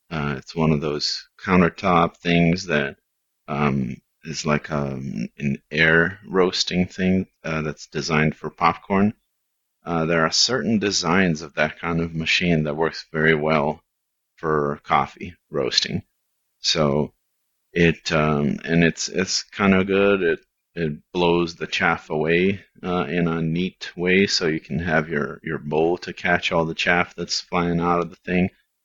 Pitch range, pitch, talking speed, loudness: 75-90 Hz, 85 Hz, 160 wpm, -22 LUFS